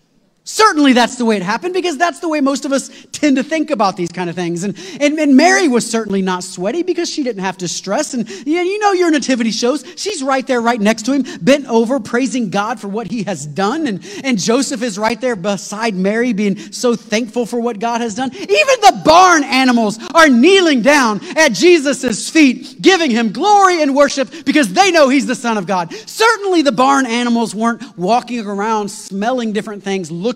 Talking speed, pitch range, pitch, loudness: 210 wpm, 220-295 Hz, 245 Hz, -14 LUFS